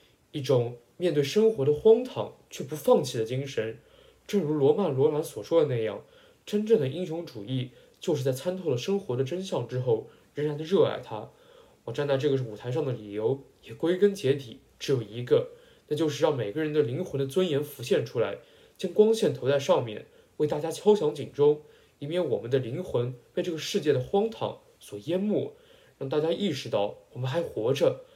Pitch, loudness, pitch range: 150 Hz, -28 LUFS, 135-200 Hz